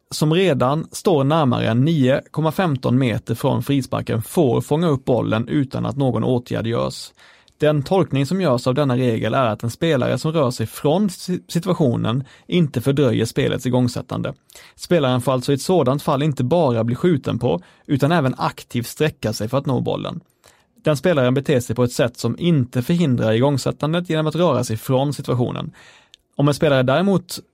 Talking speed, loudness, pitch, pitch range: 170 wpm, -19 LUFS, 140 Hz, 125-155 Hz